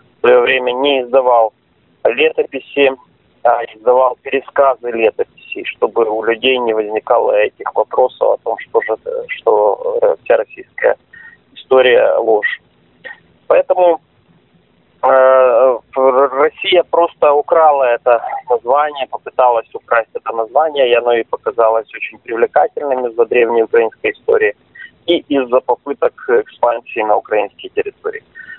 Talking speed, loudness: 115 wpm, -14 LUFS